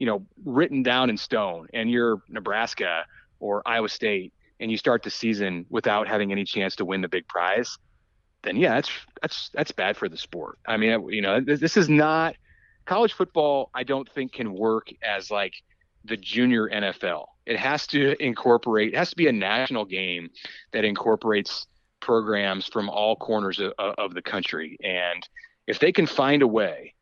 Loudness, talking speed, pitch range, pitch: -25 LUFS, 180 wpm, 105-135 Hz, 115 Hz